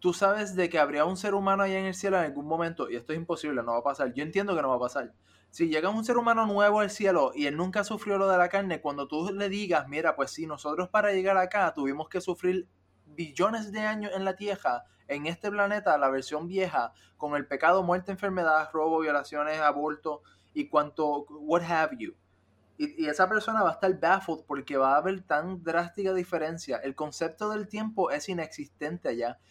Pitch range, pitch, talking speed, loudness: 150-195 Hz, 170 Hz, 220 wpm, -29 LUFS